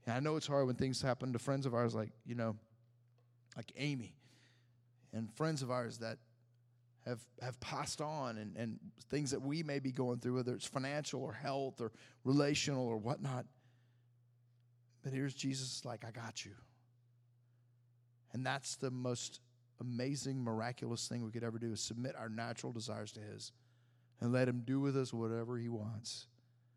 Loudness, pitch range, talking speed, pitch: -41 LUFS, 115-130 Hz, 175 wpm, 120 Hz